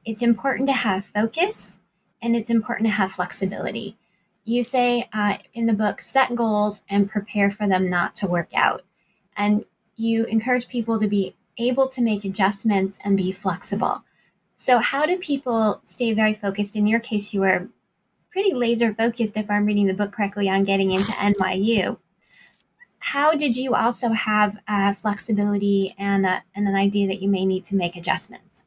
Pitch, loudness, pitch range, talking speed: 210 Hz, -22 LUFS, 195-235 Hz, 175 wpm